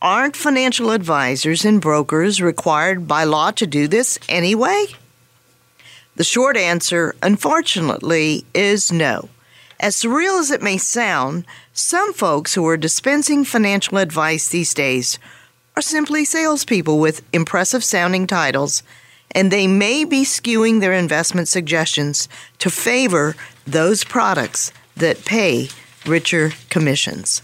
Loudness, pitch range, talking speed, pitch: -17 LUFS, 155-230 Hz, 120 wpm, 185 Hz